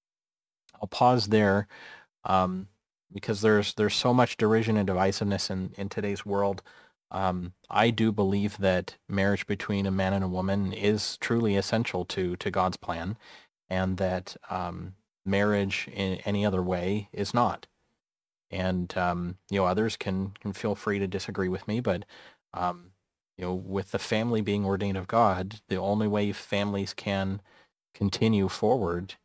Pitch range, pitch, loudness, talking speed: 95-105 Hz, 100 Hz, -28 LUFS, 155 wpm